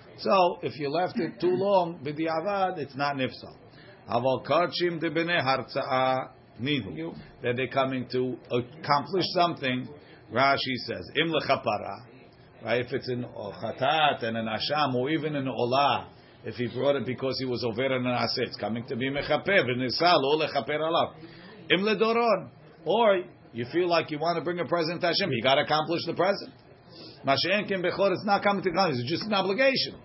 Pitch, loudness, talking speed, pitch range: 140 Hz, -27 LUFS, 170 wpm, 125-170 Hz